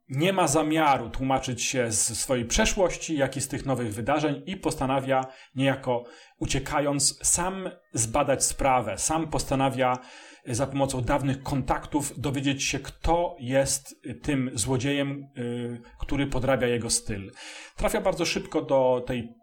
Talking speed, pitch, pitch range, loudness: 130 wpm, 135 Hz, 125-150 Hz, -26 LUFS